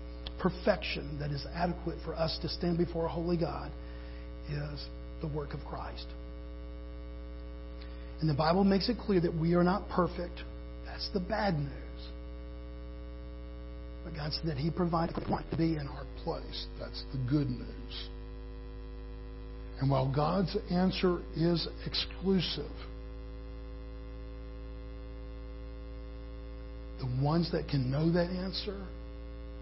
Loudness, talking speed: -33 LUFS, 125 wpm